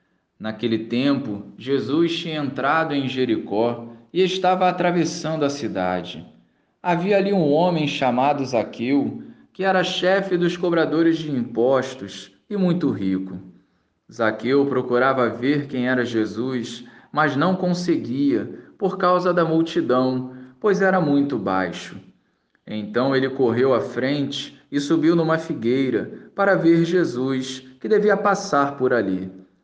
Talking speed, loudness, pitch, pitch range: 125 wpm, -21 LUFS, 140 Hz, 120-175 Hz